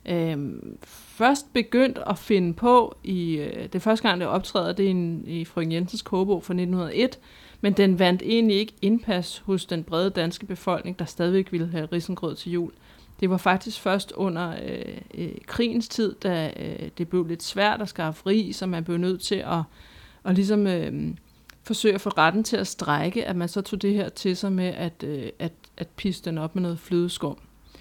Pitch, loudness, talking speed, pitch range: 185 Hz, -25 LUFS, 205 wpm, 170-205 Hz